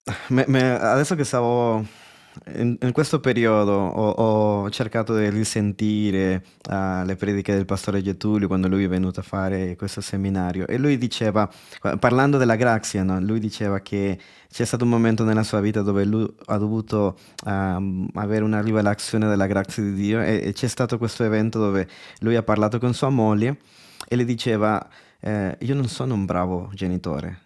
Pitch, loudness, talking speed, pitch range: 105 Hz, -22 LUFS, 175 wpm, 100-115 Hz